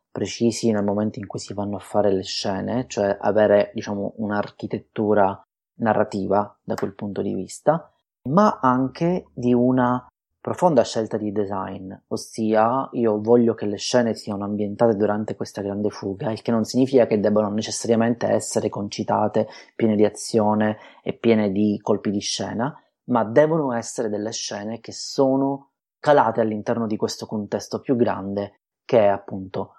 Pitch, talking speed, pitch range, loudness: 110 Hz, 155 wpm, 105-115 Hz, -22 LUFS